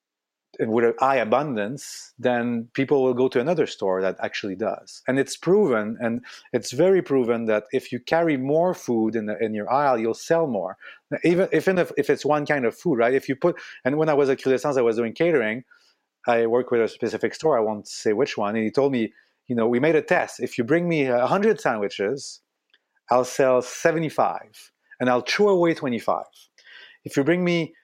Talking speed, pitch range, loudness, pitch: 215 wpm, 115-160 Hz, -23 LUFS, 130 Hz